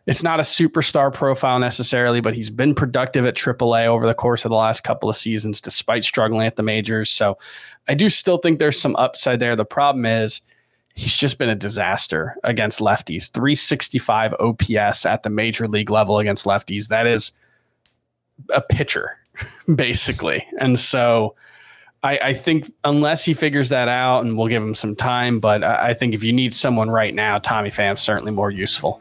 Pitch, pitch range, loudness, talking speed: 115 Hz, 110-135 Hz, -18 LUFS, 185 wpm